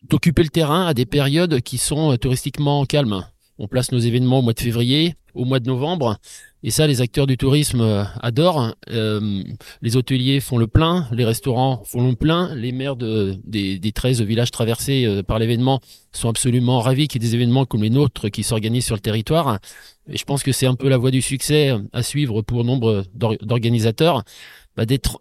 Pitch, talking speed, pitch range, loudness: 125 Hz, 205 wpm, 115-135 Hz, -19 LUFS